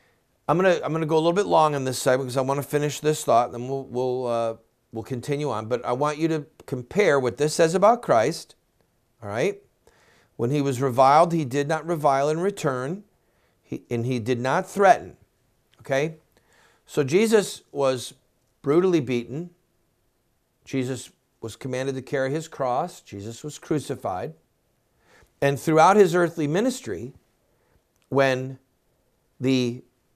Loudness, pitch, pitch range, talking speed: -23 LUFS, 140 Hz, 125-160 Hz, 155 wpm